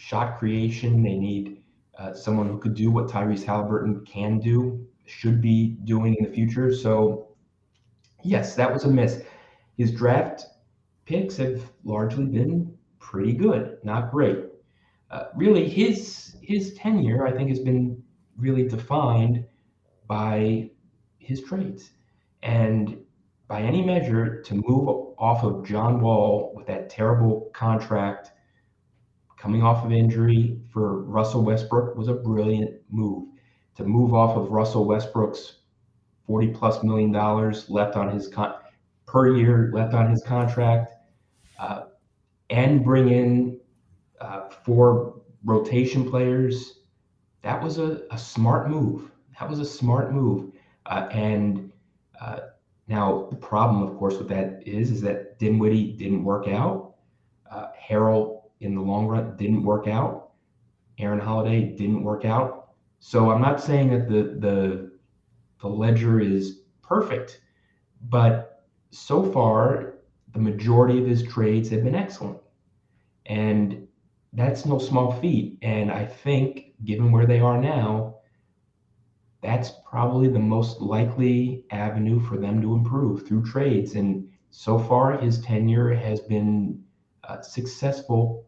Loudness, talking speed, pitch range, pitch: -23 LUFS, 135 wpm, 105-125 Hz, 115 Hz